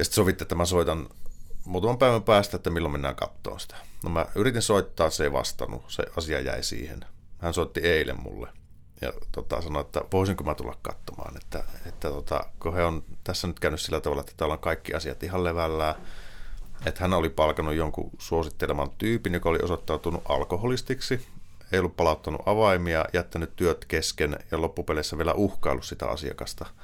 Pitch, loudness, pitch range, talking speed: 85 Hz, -28 LUFS, 80-95 Hz, 180 wpm